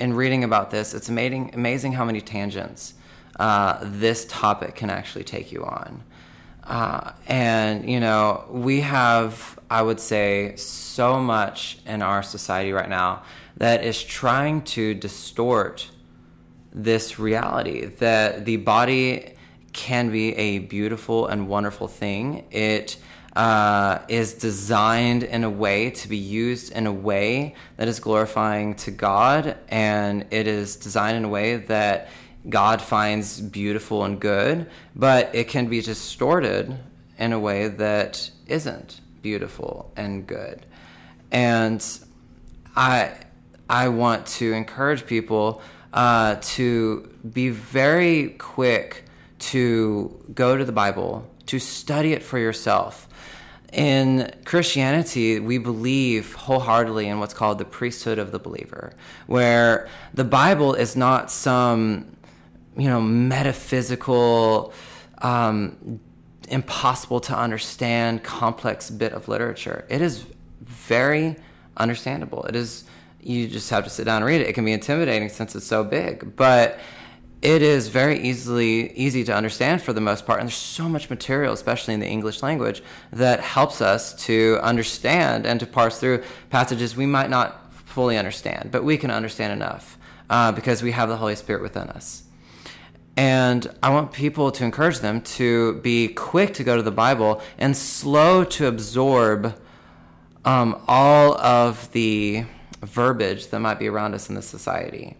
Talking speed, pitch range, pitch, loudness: 145 wpm, 105-125 Hz, 115 Hz, -22 LUFS